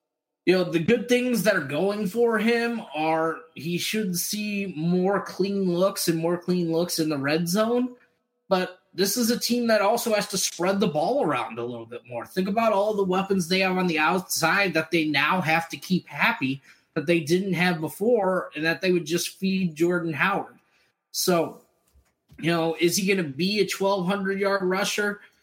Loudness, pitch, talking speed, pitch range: -24 LUFS, 185 Hz, 200 wpm, 165-200 Hz